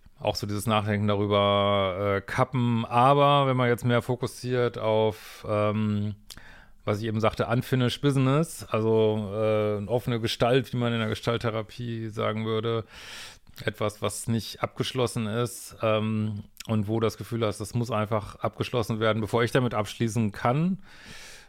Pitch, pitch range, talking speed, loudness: 110 Hz, 105-120 Hz, 150 wpm, -26 LUFS